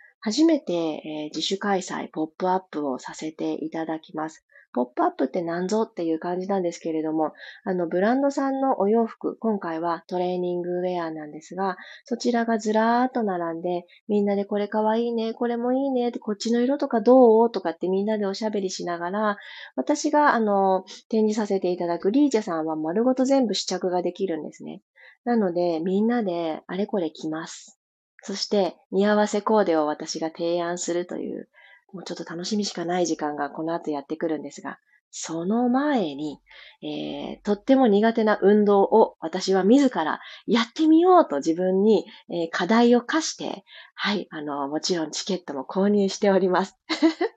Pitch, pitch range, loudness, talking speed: 195 Hz, 170-230 Hz, -24 LUFS, 360 characters per minute